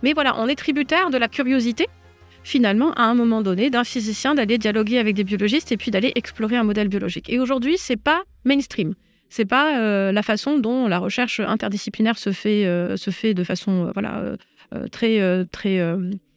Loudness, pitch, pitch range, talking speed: -21 LUFS, 220 Hz, 200-255 Hz, 200 wpm